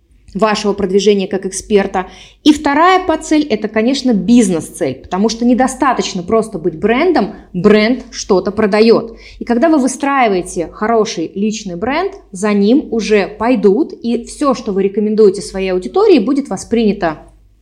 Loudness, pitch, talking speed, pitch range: -13 LUFS, 215 Hz, 135 wpm, 195-255 Hz